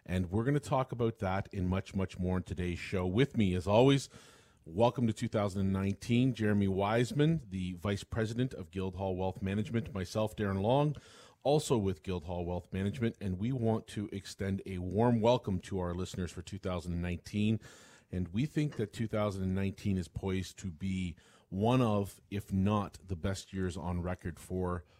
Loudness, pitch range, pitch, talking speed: -34 LUFS, 95-115 Hz, 100 Hz, 170 wpm